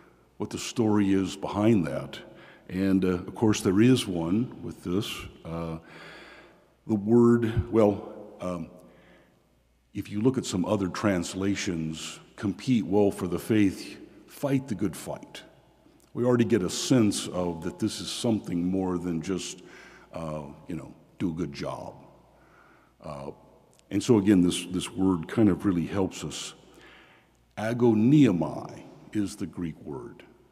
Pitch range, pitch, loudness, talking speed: 90-110 Hz, 95 Hz, -27 LUFS, 145 wpm